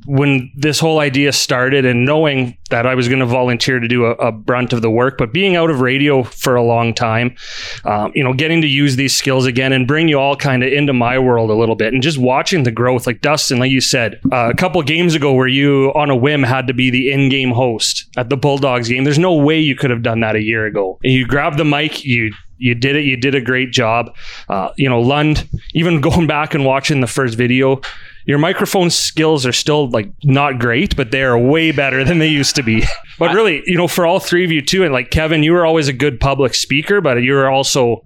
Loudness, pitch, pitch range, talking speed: -14 LUFS, 135 Hz, 125-150 Hz, 250 wpm